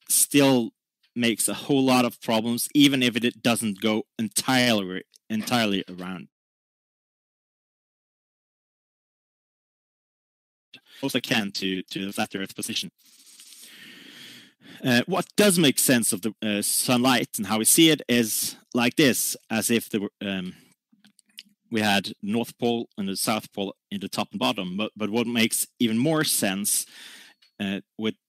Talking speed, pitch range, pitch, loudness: 140 wpm, 100-130 Hz, 115 Hz, -23 LUFS